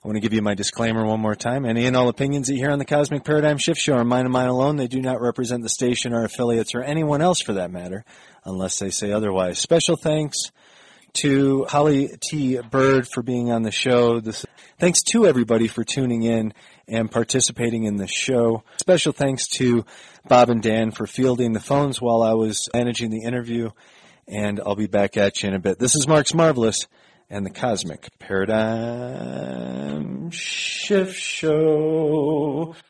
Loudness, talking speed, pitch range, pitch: -21 LUFS, 190 wpm, 110-145 Hz, 120 Hz